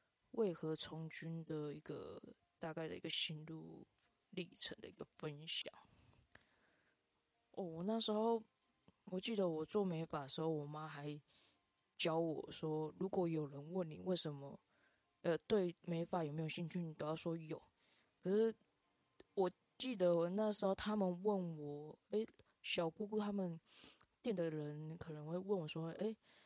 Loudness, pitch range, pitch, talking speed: -43 LUFS, 155-195 Hz, 170 Hz, 220 characters per minute